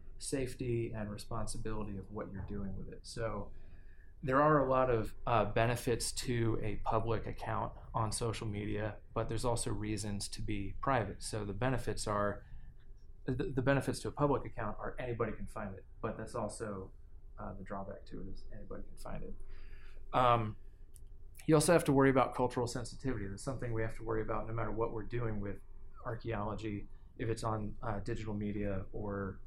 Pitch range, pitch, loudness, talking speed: 100-120 Hz, 110 Hz, -36 LUFS, 180 wpm